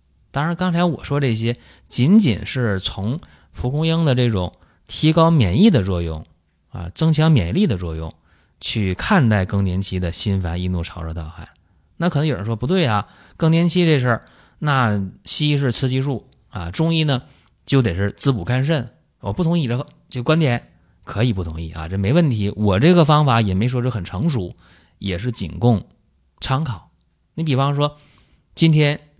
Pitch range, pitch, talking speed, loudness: 95-150 Hz, 120 Hz, 255 characters per minute, -19 LUFS